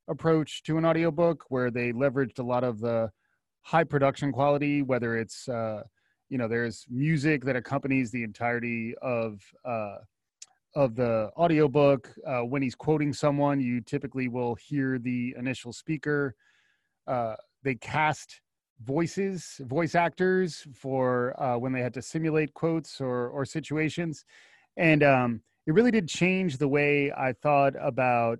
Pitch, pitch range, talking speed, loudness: 140 Hz, 125-155 Hz, 150 wpm, -28 LUFS